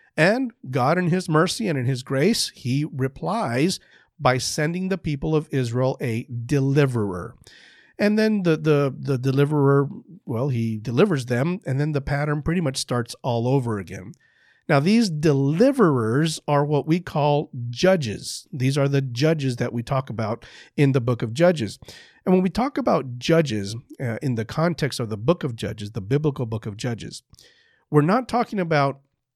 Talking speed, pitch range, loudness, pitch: 170 wpm, 125-165 Hz, -22 LUFS, 140 Hz